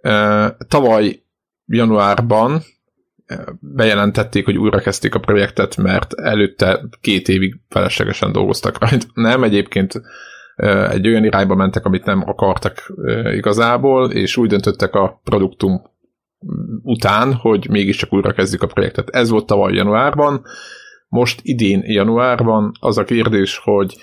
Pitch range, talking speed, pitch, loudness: 100-120 Hz, 115 wpm, 105 Hz, -15 LUFS